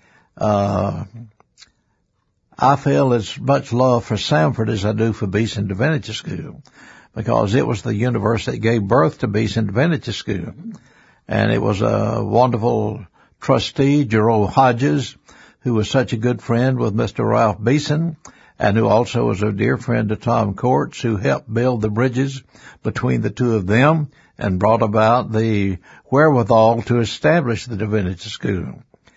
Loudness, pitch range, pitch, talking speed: -18 LUFS, 110-130 Hz, 115 Hz, 155 wpm